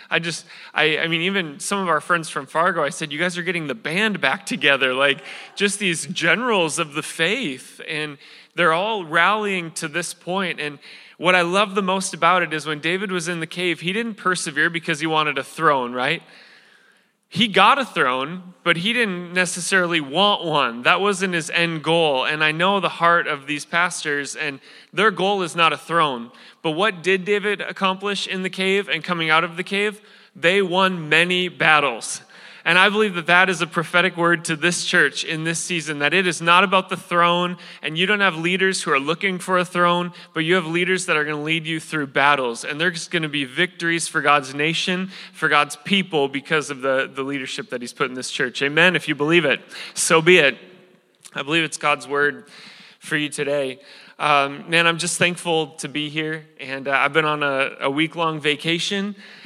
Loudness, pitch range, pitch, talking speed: -20 LUFS, 155-185 Hz, 170 Hz, 210 wpm